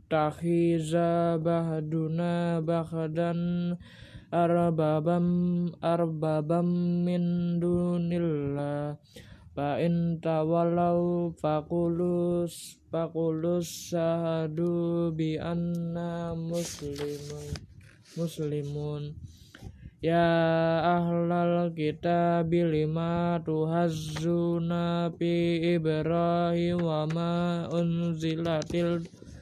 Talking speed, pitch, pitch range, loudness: 50 wpm, 170 Hz, 160-170 Hz, -28 LUFS